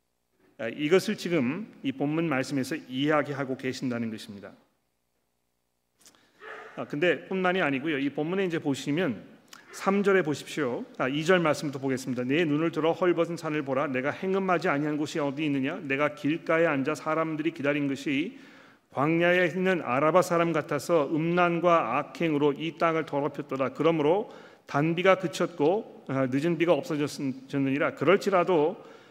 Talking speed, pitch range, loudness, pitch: 330 characters per minute, 140-175 Hz, -27 LUFS, 155 Hz